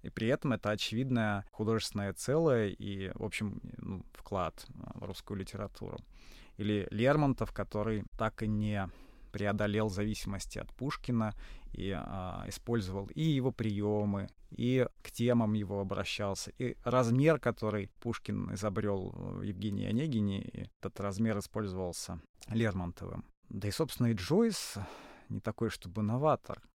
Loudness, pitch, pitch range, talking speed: -35 LUFS, 105 Hz, 100-115 Hz, 130 wpm